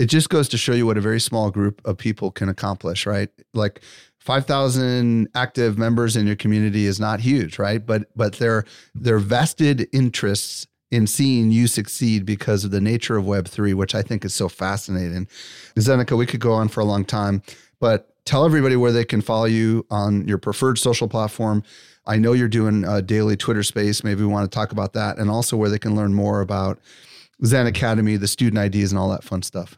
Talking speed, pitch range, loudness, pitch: 210 wpm, 100-120 Hz, -20 LUFS, 110 Hz